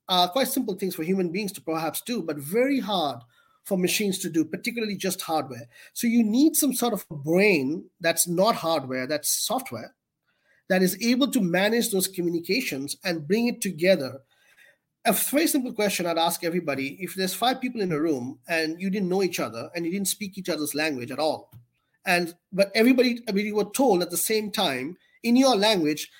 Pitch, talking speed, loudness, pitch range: 185 Hz, 200 wpm, -25 LUFS, 160-215 Hz